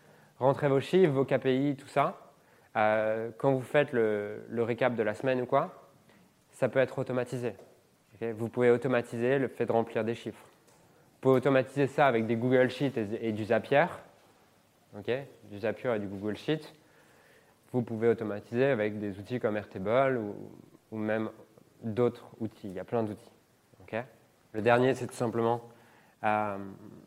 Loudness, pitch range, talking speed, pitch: -30 LUFS, 110-130 Hz, 170 wpm, 120 Hz